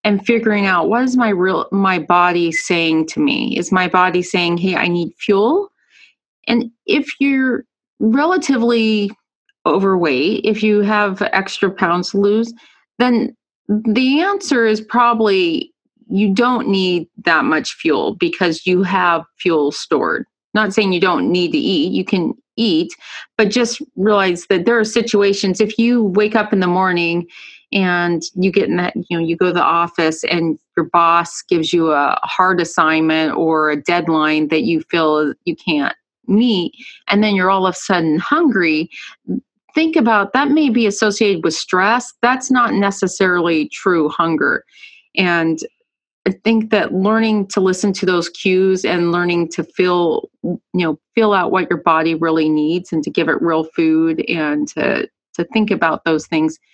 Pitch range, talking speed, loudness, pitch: 170-235 Hz, 165 wpm, -16 LUFS, 195 Hz